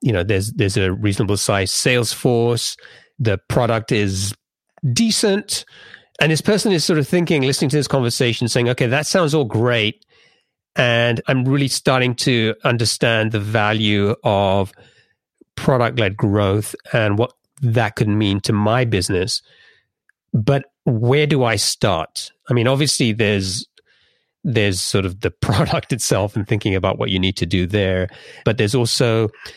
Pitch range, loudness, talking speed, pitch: 105-130 Hz, -18 LUFS, 155 wpm, 115 Hz